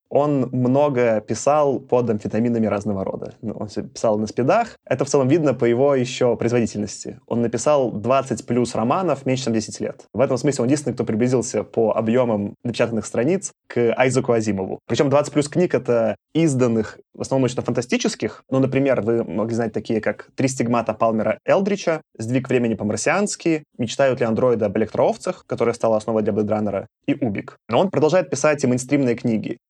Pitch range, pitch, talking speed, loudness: 110-135 Hz, 120 Hz, 170 wpm, -21 LUFS